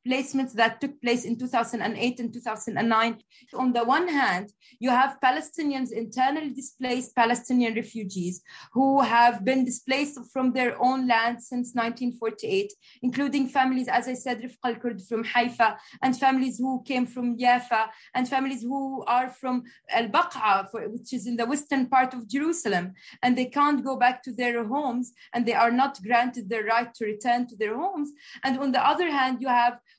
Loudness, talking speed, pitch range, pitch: -26 LUFS, 170 wpm, 235-265 Hz, 250 Hz